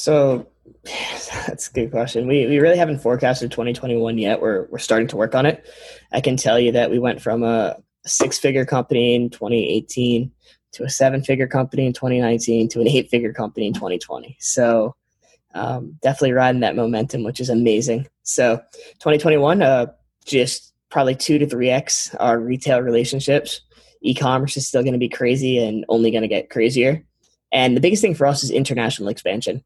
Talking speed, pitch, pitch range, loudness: 180 wpm, 125 Hz, 115-135 Hz, -19 LUFS